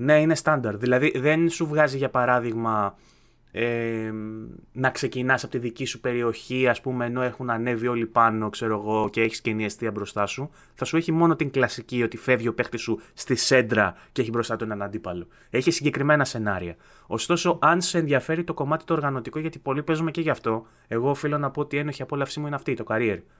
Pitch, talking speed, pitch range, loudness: 125 Hz, 210 wpm, 115-150 Hz, -25 LUFS